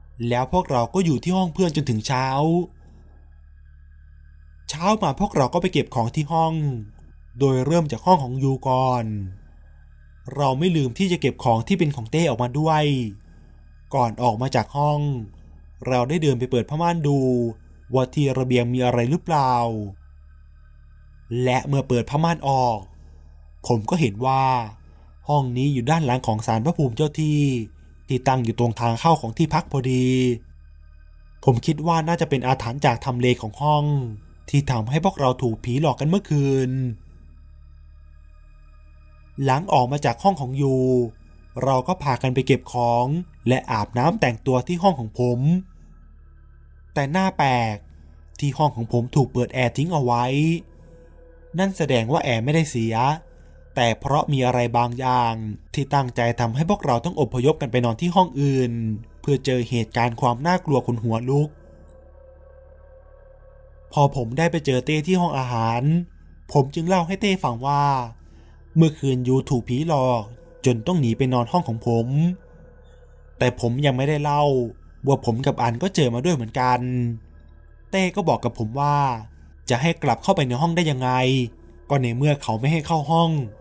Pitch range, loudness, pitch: 110-145 Hz, -22 LUFS, 125 Hz